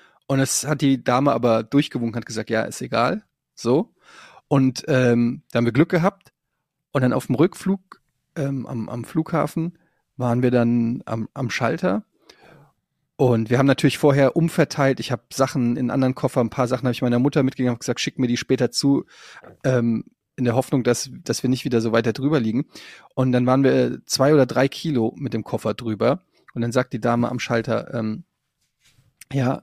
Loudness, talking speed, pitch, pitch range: -21 LUFS, 195 wpm, 130 Hz, 120-140 Hz